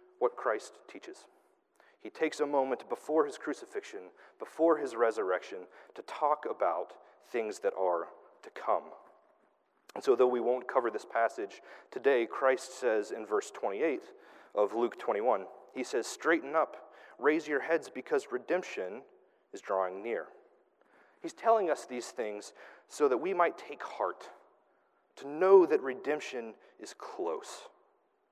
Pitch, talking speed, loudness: 395 Hz, 140 wpm, -32 LUFS